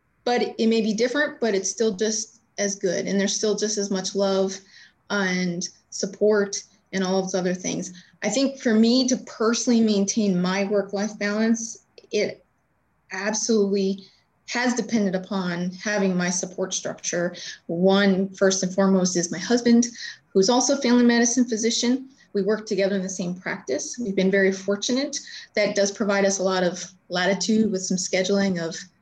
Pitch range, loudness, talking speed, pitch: 190-225 Hz, -23 LUFS, 165 wpm, 200 Hz